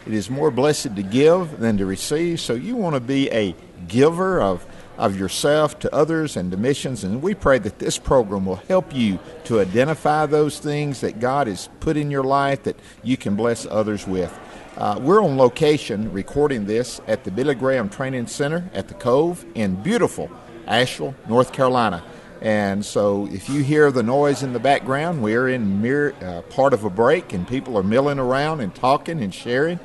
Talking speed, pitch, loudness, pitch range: 195 wpm, 130 Hz, -20 LUFS, 105-150 Hz